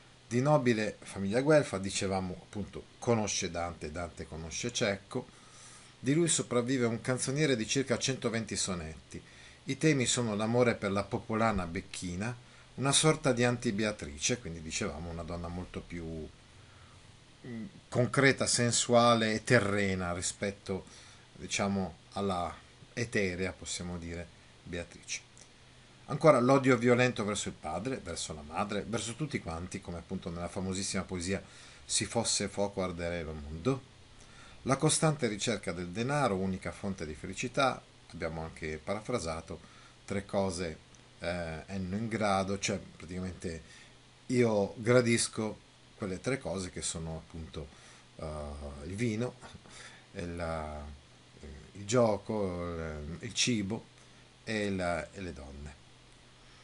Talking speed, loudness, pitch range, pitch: 120 wpm, -32 LUFS, 85-120 Hz, 100 Hz